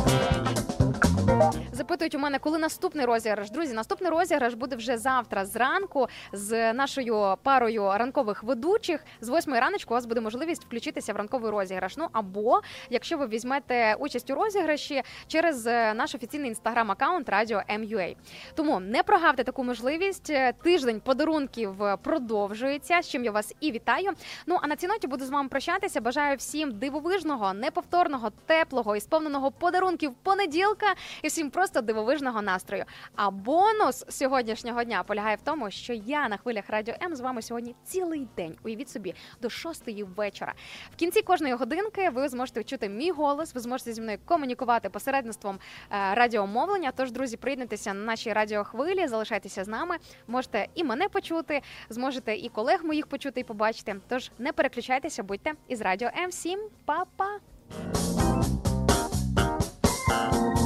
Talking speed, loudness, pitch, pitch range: 145 wpm, -28 LUFS, 260 Hz, 225-320 Hz